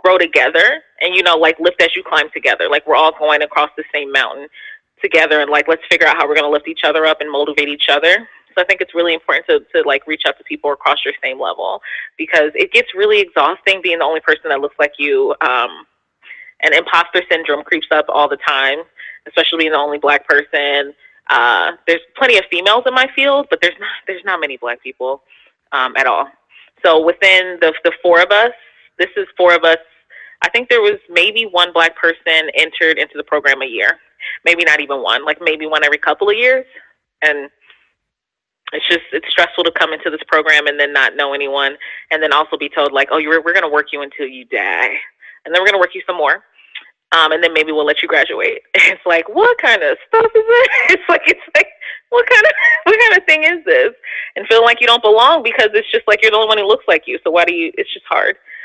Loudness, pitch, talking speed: -13 LUFS, 170 Hz, 235 wpm